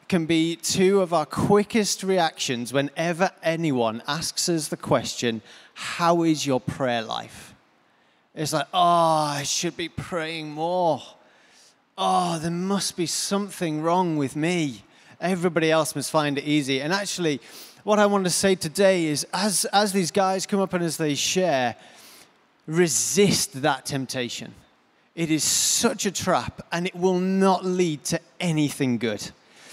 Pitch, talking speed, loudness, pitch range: 165 Hz, 150 wpm, -23 LUFS, 145-185 Hz